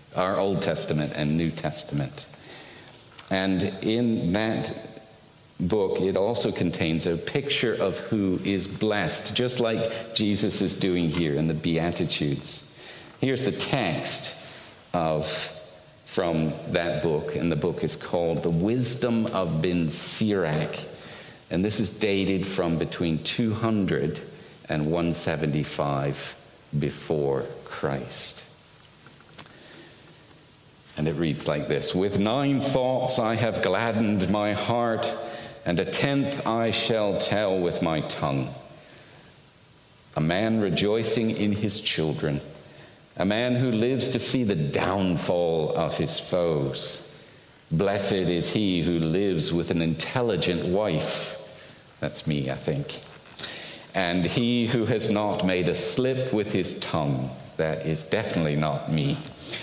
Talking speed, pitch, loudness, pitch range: 125 wpm, 95 Hz, -26 LUFS, 80-115 Hz